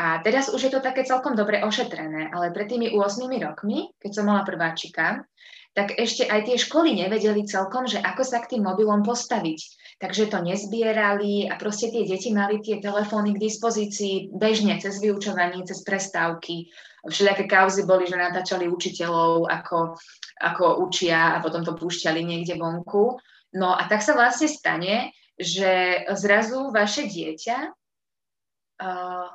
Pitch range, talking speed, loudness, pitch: 180-225 Hz, 155 wpm, -23 LUFS, 200 Hz